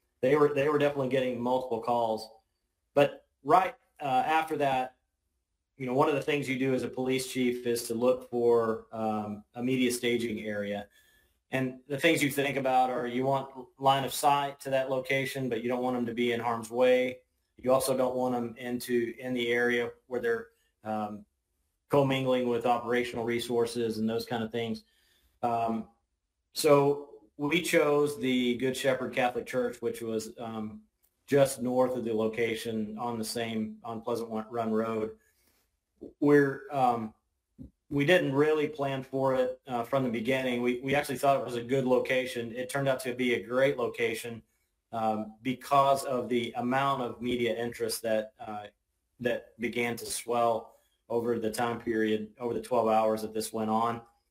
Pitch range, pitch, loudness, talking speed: 115-130 Hz, 120 Hz, -29 LUFS, 175 wpm